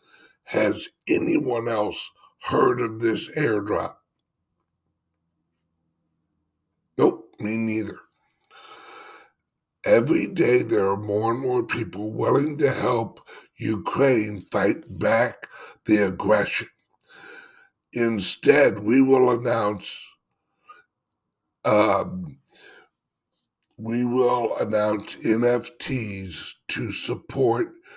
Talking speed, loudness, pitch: 80 wpm, -23 LUFS, 120 Hz